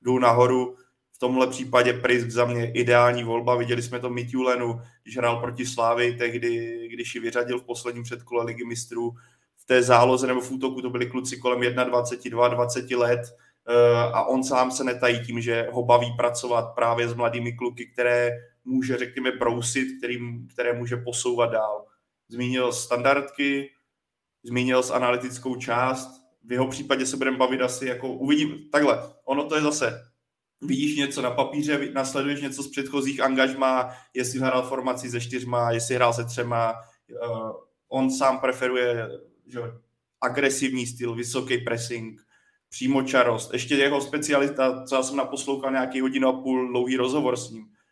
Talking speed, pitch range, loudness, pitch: 155 wpm, 120-130 Hz, -24 LUFS, 125 Hz